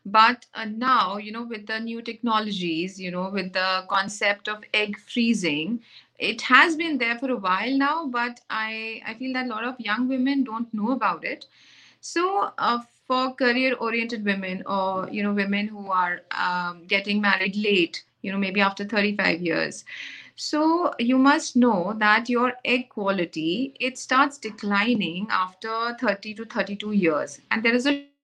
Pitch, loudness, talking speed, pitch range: 220 Hz, -24 LUFS, 170 wpm, 200-250 Hz